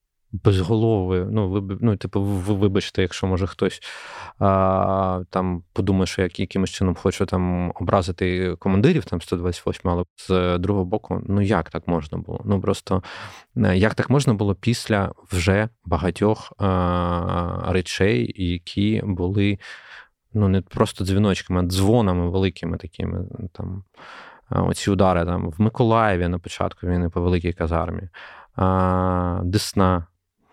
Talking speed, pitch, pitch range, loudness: 135 wpm, 95 Hz, 90-105 Hz, -22 LUFS